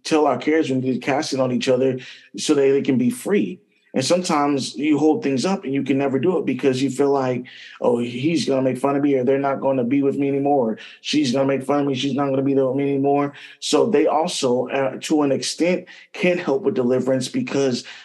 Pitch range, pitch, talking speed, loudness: 130-145 Hz, 135 Hz, 265 wpm, -20 LUFS